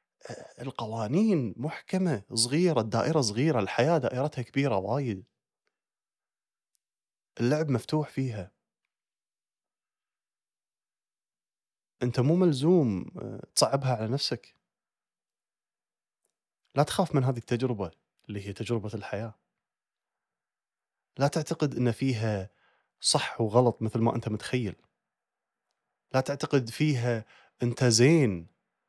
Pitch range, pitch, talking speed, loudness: 115-145 Hz, 125 Hz, 85 wpm, -28 LUFS